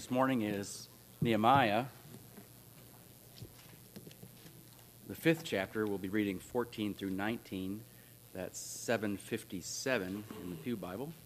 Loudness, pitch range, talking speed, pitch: -36 LUFS, 95-120 Hz, 100 wpm, 105 Hz